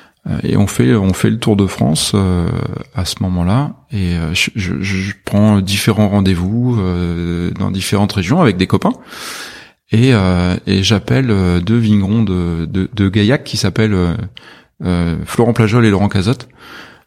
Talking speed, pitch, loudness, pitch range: 160 wpm, 100 Hz, -14 LUFS, 90-110 Hz